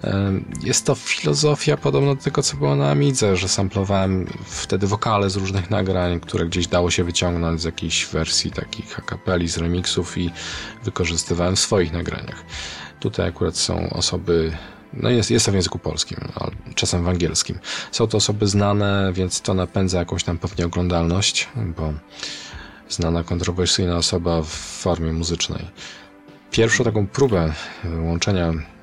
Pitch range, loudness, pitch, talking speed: 85-100 Hz, -21 LUFS, 90 Hz, 145 wpm